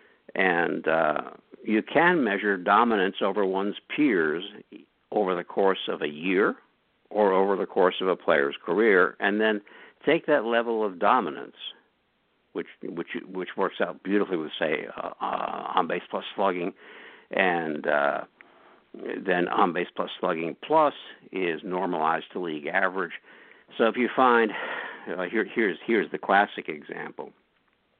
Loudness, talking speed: -26 LUFS, 145 wpm